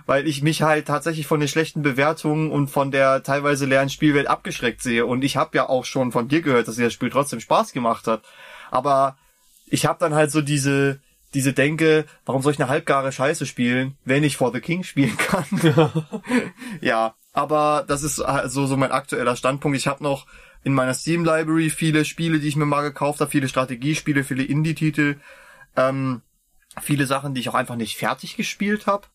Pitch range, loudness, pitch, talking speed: 135-160 Hz, -21 LUFS, 145 Hz, 195 wpm